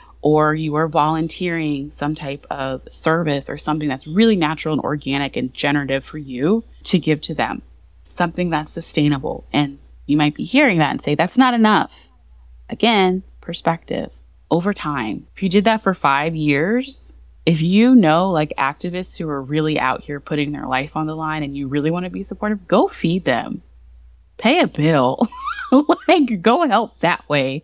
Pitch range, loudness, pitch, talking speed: 145-185 Hz, -19 LUFS, 155 Hz, 180 wpm